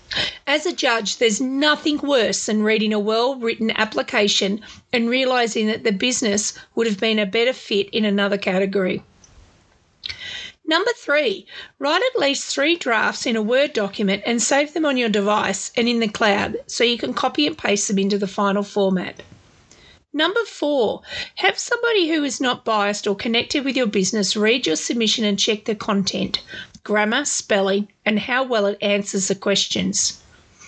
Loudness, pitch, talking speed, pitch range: -20 LUFS, 225 Hz, 170 wpm, 205-270 Hz